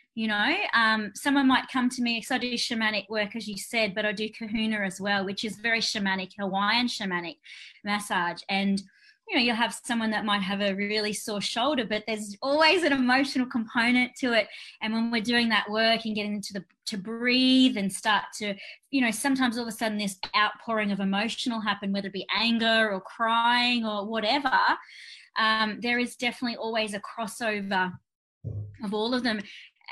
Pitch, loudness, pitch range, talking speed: 220 Hz, -26 LUFS, 205-240 Hz, 195 wpm